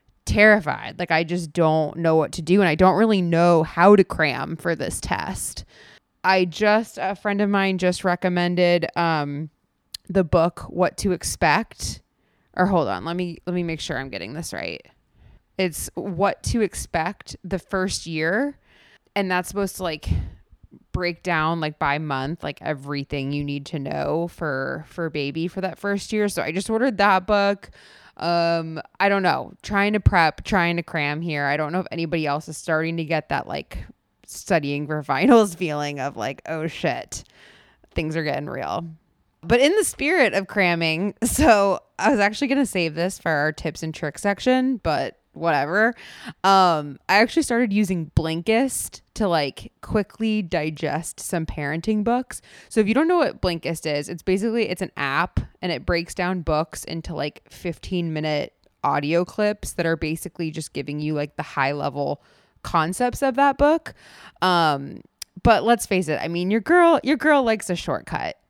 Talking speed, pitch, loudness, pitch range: 180 wpm, 175 Hz, -22 LUFS, 155-200 Hz